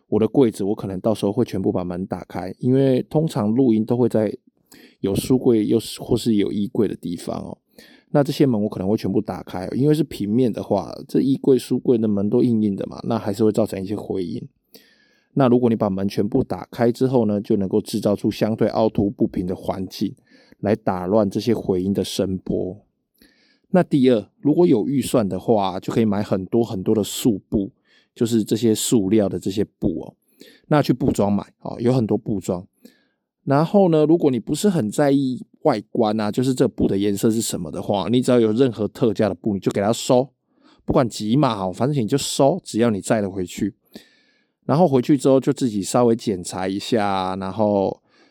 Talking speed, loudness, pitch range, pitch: 300 characters per minute, -20 LUFS, 100-135 Hz, 115 Hz